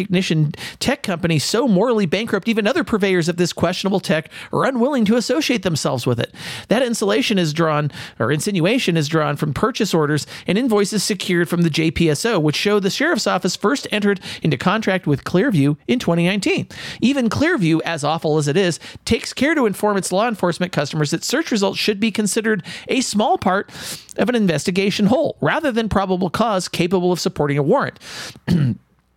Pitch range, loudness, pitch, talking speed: 165-215 Hz, -19 LUFS, 190 Hz, 180 wpm